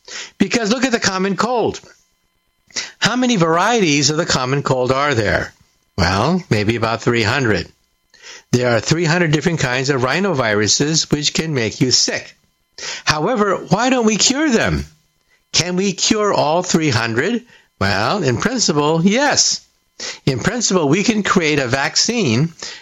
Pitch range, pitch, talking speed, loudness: 130-200 Hz, 165 Hz, 140 wpm, -16 LUFS